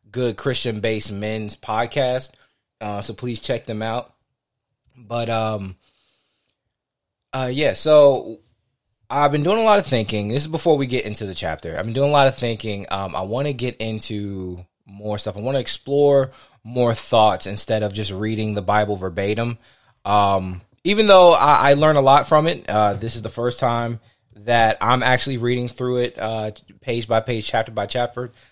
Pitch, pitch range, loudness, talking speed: 115 Hz, 105-130 Hz, -19 LUFS, 185 wpm